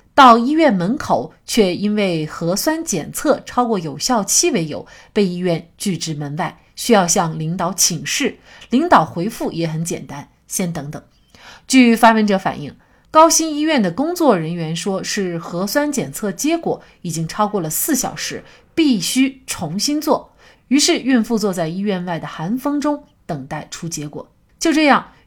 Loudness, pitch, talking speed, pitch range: -17 LUFS, 200 Hz, 240 characters per minute, 170-260 Hz